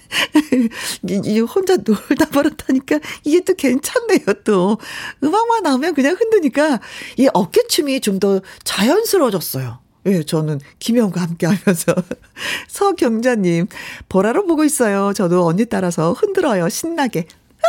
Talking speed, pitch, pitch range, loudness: 280 characters per minute, 245 Hz, 190-310 Hz, -17 LUFS